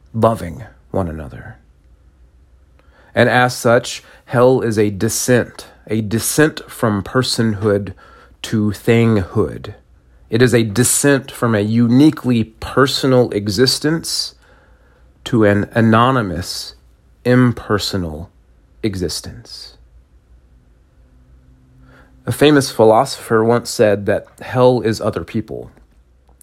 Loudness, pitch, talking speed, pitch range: -16 LUFS, 110 Hz, 90 wpm, 75-120 Hz